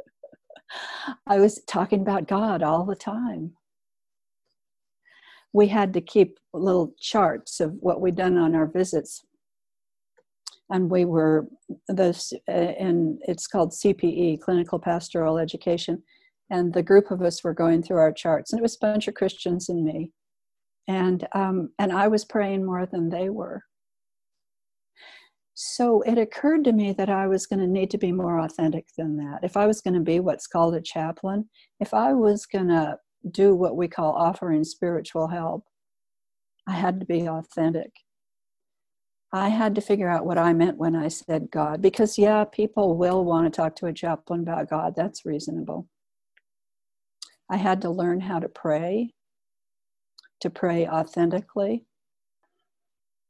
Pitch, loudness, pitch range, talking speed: 180 Hz, -24 LUFS, 165-205 Hz, 160 wpm